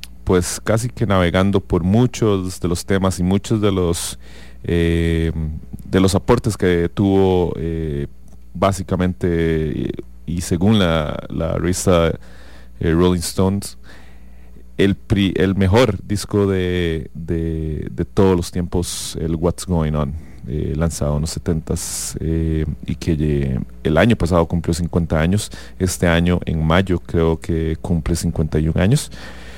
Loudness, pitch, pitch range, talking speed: -19 LUFS, 85 Hz, 80-95 Hz, 140 wpm